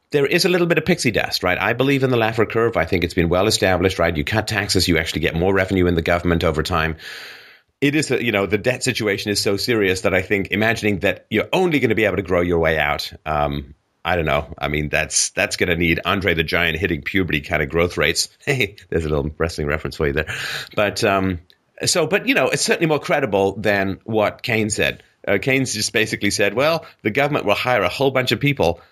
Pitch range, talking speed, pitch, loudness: 85-115 Hz, 245 wpm, 100 Hz, -19 LUFS